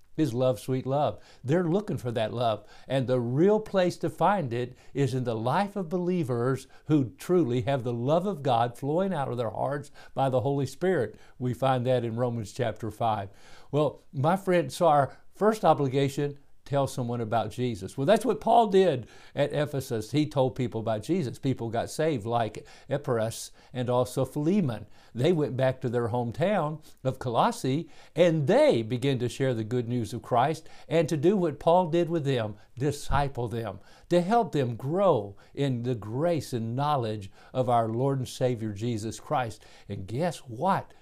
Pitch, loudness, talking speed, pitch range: 130 Hz, -28 LUFS, 180 wpm, 120-160 Hz